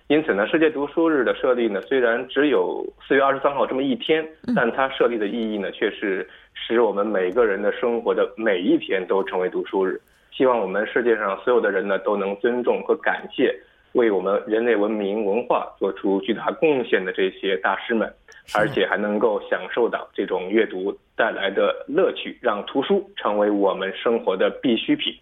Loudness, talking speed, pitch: -22 LUFS, 295 characters per minute, 395 Hz